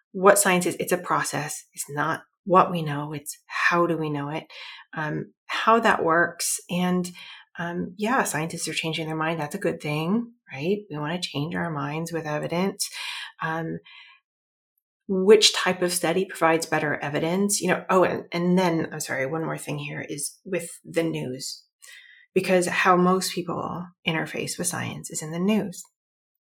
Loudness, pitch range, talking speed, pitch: -24 LUFS, 155-185 Hz, 175 wpm, 170 Hz